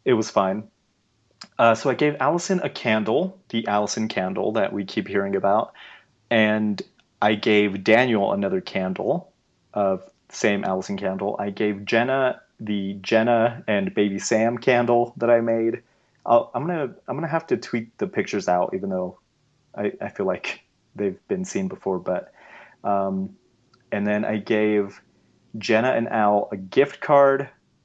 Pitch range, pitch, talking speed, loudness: 100-130 Hz, 110 Hz, 160 wpm, -23 LUFS